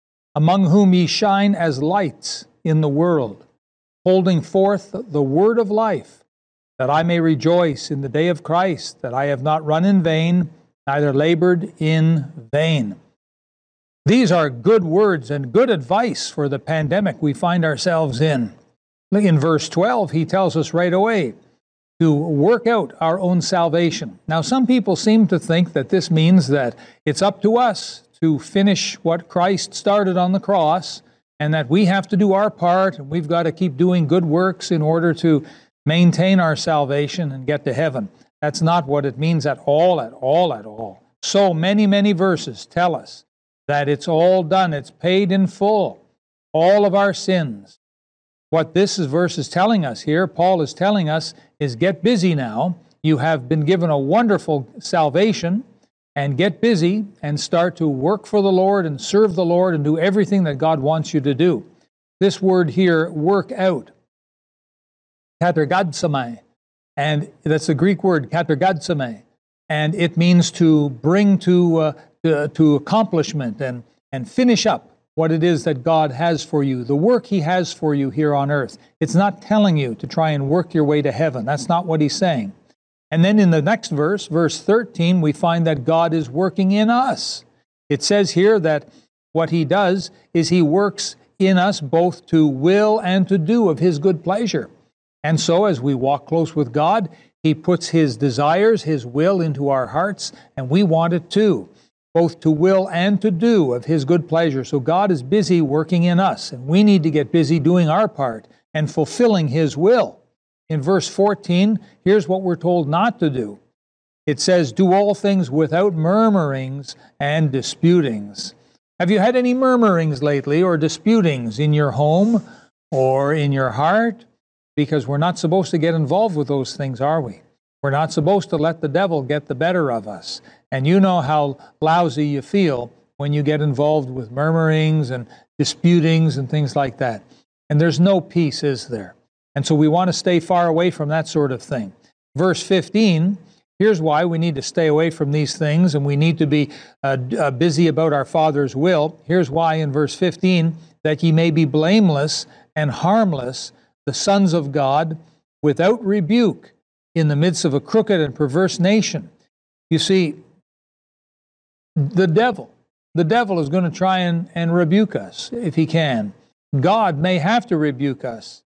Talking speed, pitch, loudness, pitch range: 180 wpm, 165 Hz, -18 LUFS, 150-190 Hz